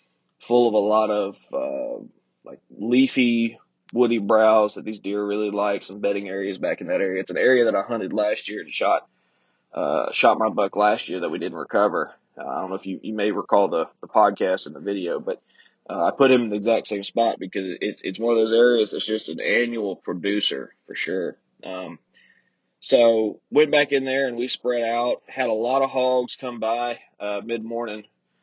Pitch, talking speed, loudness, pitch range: 110 Hz, 210 wpm, -22 LUFS, 105-120 Hz